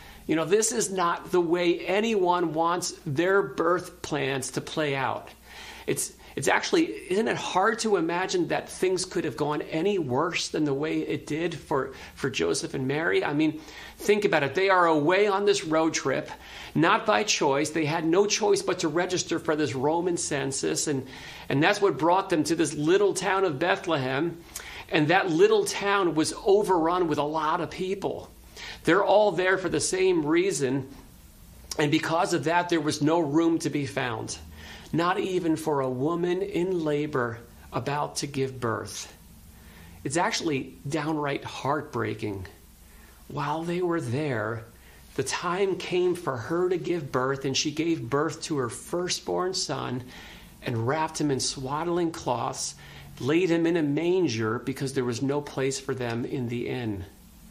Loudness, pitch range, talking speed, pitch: -26 LUFS, 135-180 Hz, 170 wpm, 160 Hz